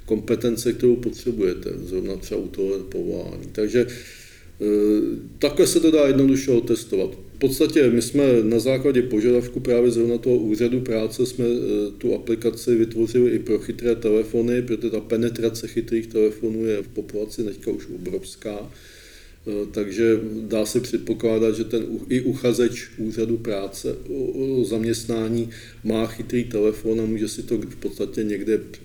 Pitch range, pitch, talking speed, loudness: 110-120 Hz, 115 Hz, 140 wpm, -22 LUFS